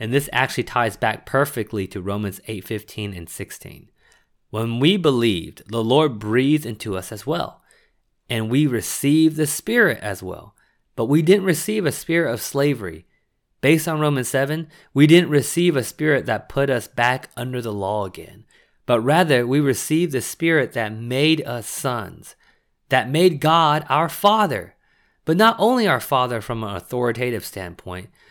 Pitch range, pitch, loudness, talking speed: 110-155 Hz, 130 Hz, -20 LUFS, 165 wpm